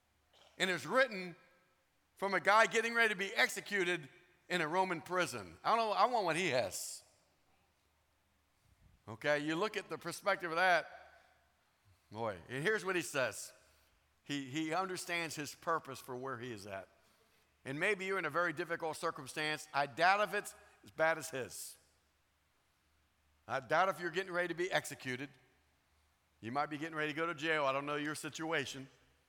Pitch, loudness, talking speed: 155 Hz, -36 LUFS, 175 wpm